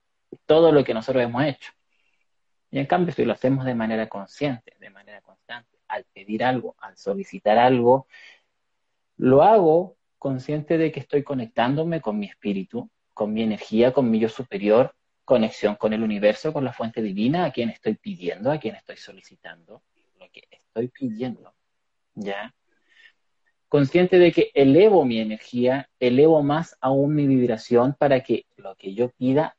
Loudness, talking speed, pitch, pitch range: -21 LUFS, 160 wpm, 130 Hz, 115-155 Hz